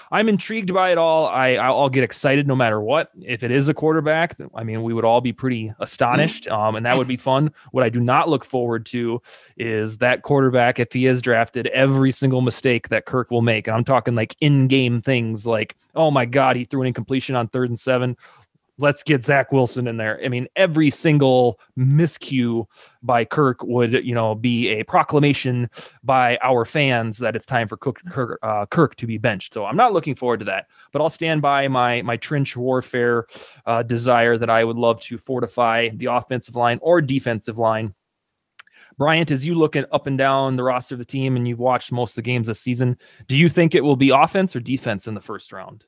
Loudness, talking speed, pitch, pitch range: -19 LUFS, 220 wpm, 125 Hz, 120-135 Hz